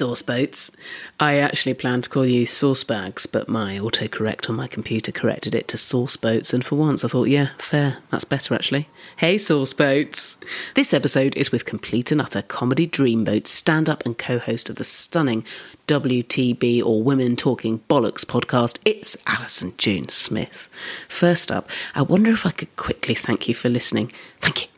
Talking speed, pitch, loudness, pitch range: 185 wpm, 130 Hz, -20 LUFS, 120-150 Hz